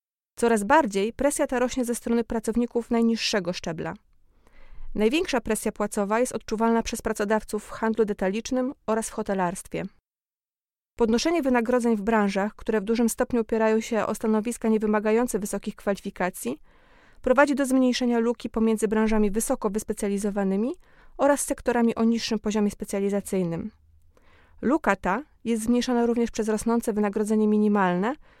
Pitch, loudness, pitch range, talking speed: 225 Hz, -25 LUFS, 210-240 Hz, 130 wpm